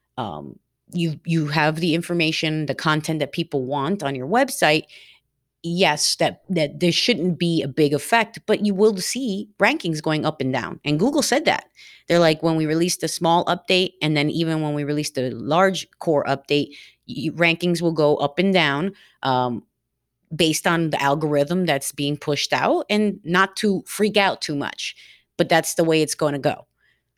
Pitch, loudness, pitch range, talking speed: 160 Hz, -21 LUFS, 150-180 Hz, 190 wpm